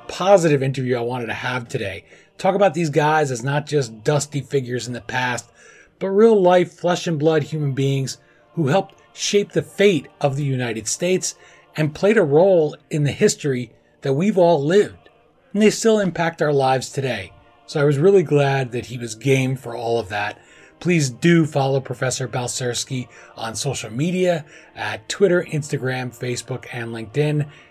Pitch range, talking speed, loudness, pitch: 125-170 Hz, 175 wpm, -20 LUFS, 140 Hz